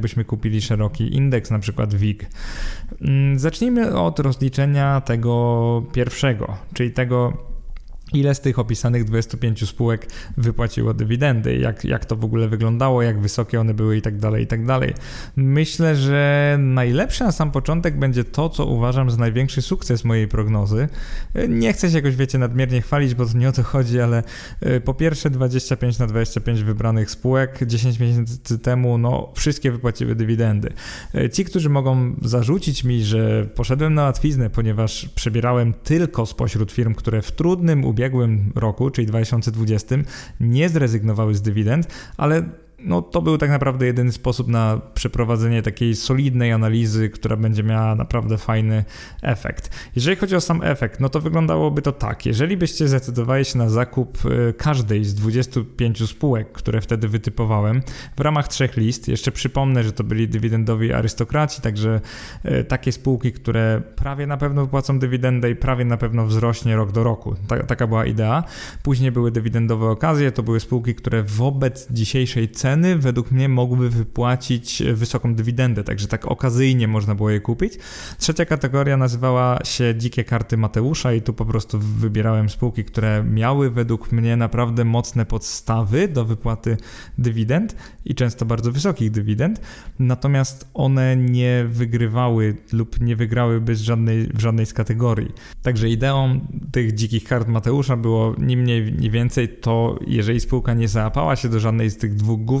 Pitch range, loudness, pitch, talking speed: 115-135 Hz, -20 LUFS, 120 Hz, 155 wpm